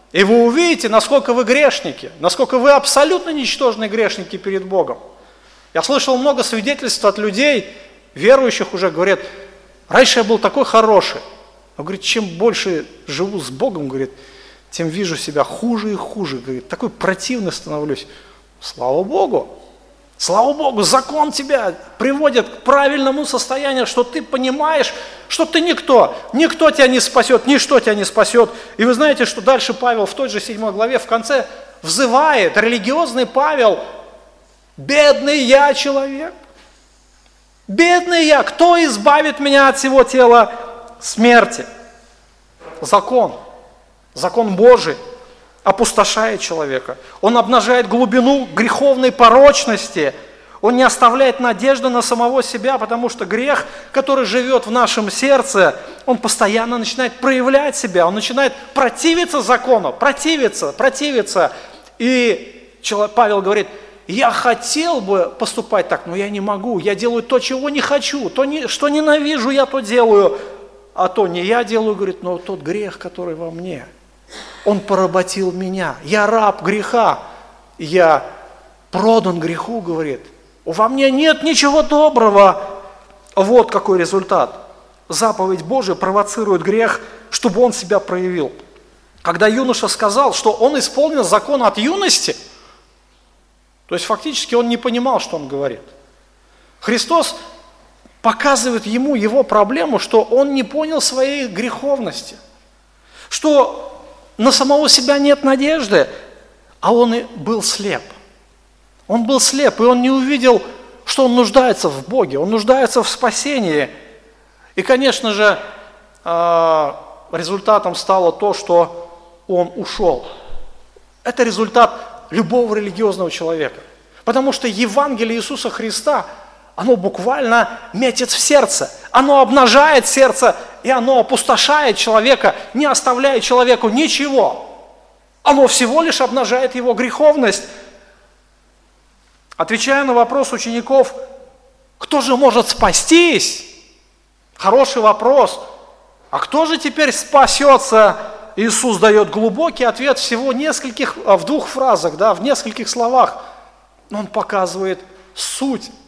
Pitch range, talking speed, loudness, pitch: 205-275 Hz, 125 wpm, -14 LUFS, 240 Hz